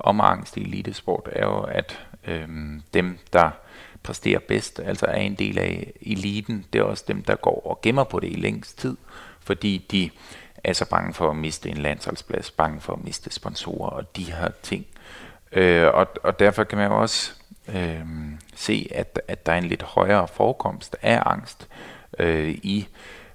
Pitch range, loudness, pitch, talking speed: 80-100 Hz, -24 LUFS, 90 Hz, 185 wpm